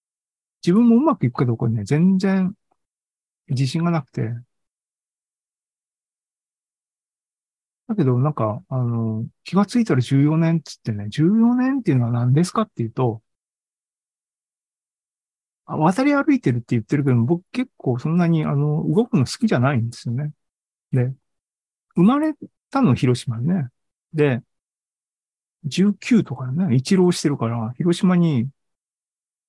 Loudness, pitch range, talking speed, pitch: -20 LUFS, 125-185 Hz, 240 characters per minute, 150 Hz